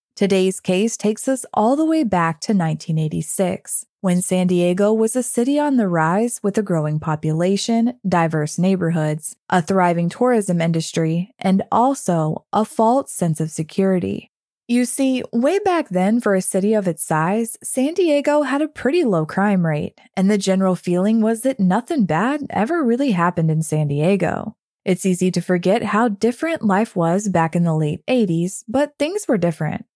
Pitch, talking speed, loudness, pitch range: 195 Hz, 170 wpm, -19 LUFS, 170-235 Hz